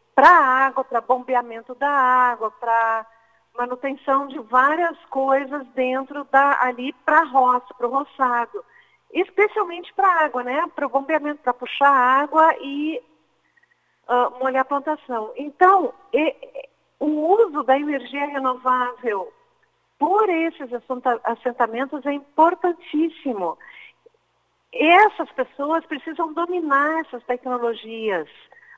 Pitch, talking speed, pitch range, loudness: 280 Hz, 110 wpm, 250-330 Hz, -20 LUFS